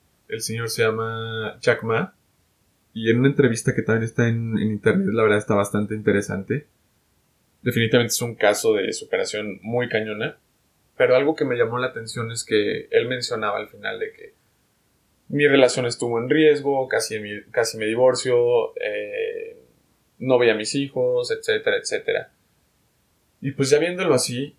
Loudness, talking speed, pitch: -22 LUFS, 165 wpm, 125 Hz